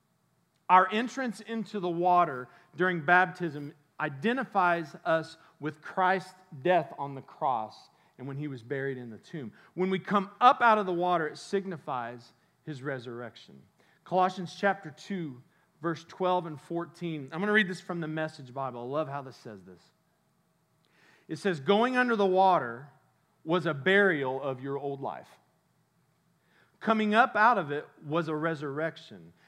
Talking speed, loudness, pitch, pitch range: 160 wpm, -29 LUFS, 165 Hz, 145-185 Hz